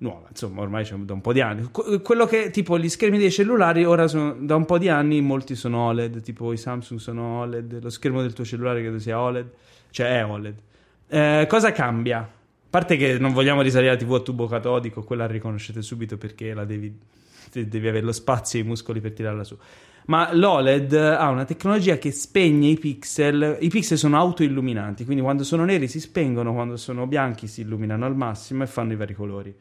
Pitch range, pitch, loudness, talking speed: 115-150 Hz, 125 Hz, -22 LUFS, 215 wpm